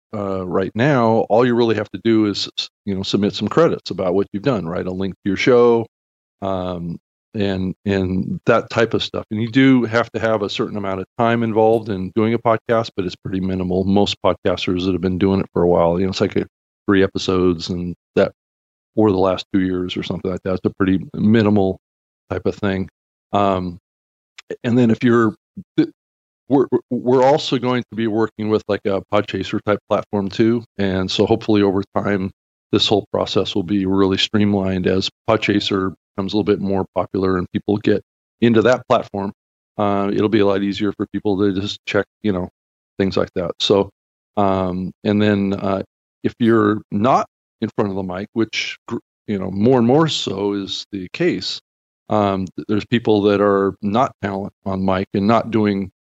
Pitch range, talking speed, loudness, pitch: 95-110 Hz, 195 wpm, -19 LUFS, 100 Hz